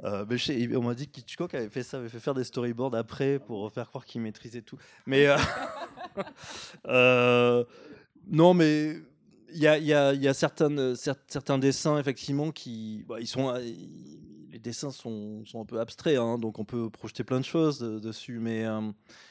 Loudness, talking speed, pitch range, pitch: -28 LUFS, 185 wpm, 115-140 Hz, 125 Hz